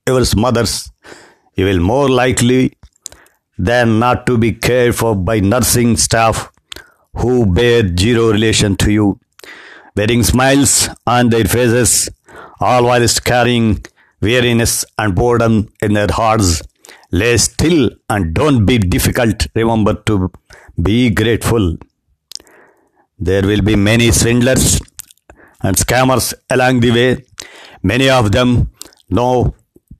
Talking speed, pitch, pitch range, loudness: 115 wpm, 115 Hz, 100-120 Hz, -13 LUFS